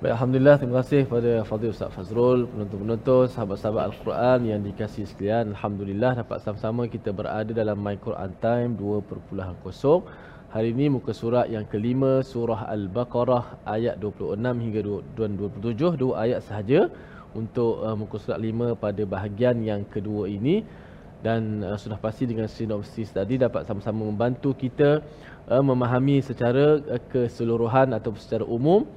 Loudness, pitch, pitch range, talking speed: -25 LUFS, 115 Hz, 105-125 Hz, 130 wpm